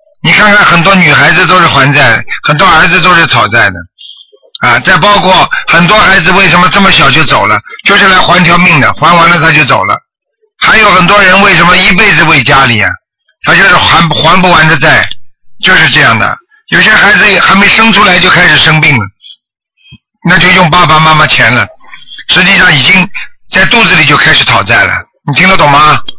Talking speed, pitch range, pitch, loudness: 285 characters per minute, 155-200 Hz, 180 Hz, -3 LUFS